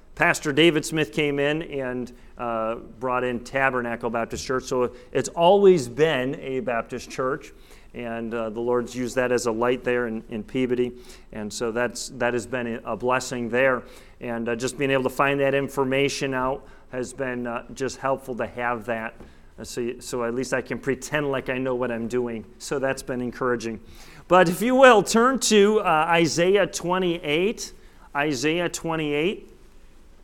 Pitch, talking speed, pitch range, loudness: 130 Hz, 175 wpm, 120-145 Hz, -23 LUFS